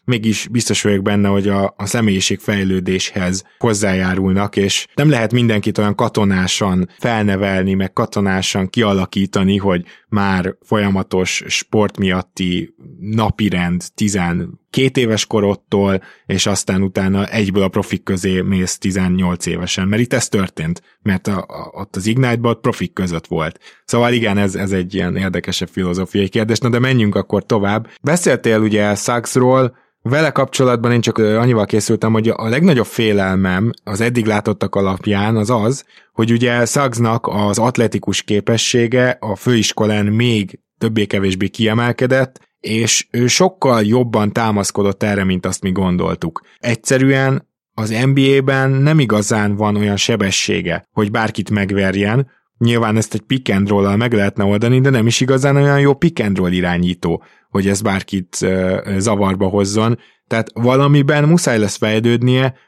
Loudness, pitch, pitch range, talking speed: -16 LUFS, 105 Hz, 95-120 Hz, 135 wpm